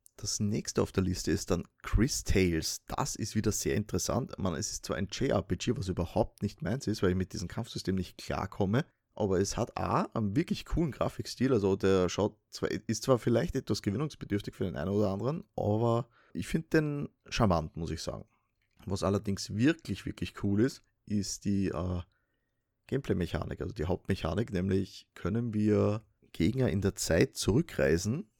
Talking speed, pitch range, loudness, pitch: 175 wpm, 95-110 Hz, -32 LUFS, 105 Hz